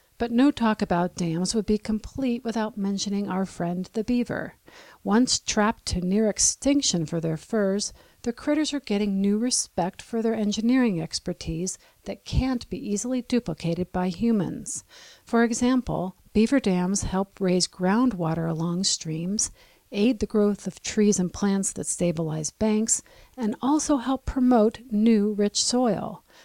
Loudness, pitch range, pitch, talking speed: -25 LUFS, 180-235 Hz, 210 Hz, 145 wpm